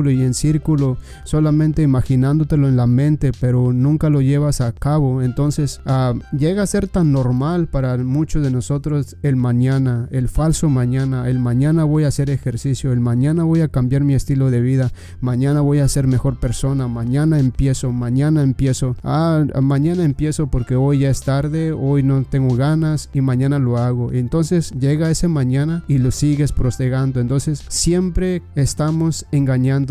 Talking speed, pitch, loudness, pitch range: 165 wpm, 135 Hz, -17 LUFS, 130-150 Hz